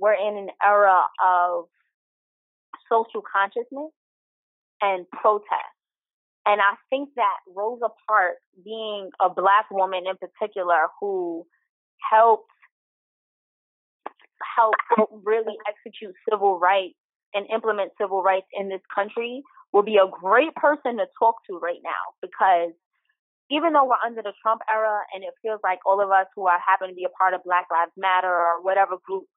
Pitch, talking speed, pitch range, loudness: 205 Hz, 150 wpm, 190-225 Hz, -23 LUFS